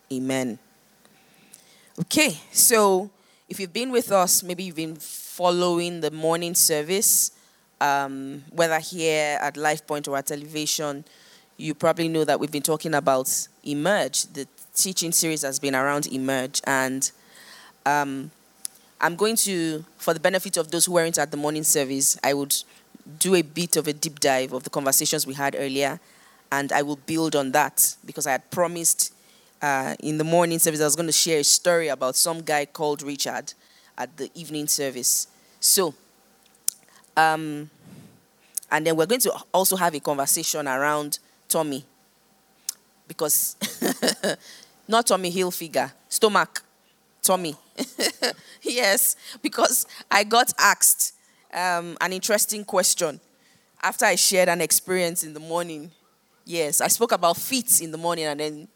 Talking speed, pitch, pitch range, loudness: 150 wpm, 160 Hz, 145-180 Hz, -22 LUFS